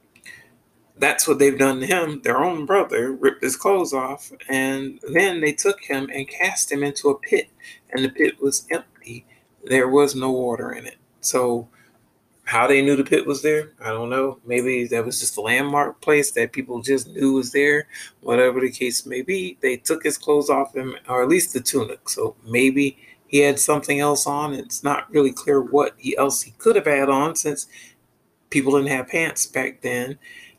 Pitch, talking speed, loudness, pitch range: 135 Hz, 195 wpm, -20 LUFS, 130-145 Hz